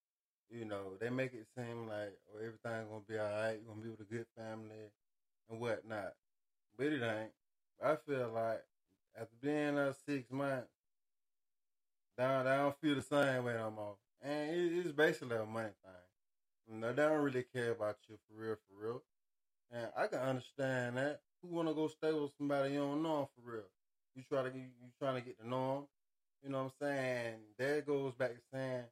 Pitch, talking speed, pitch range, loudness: 125 Hz, 200 wpm, 110-140 Hz, -40 LUFS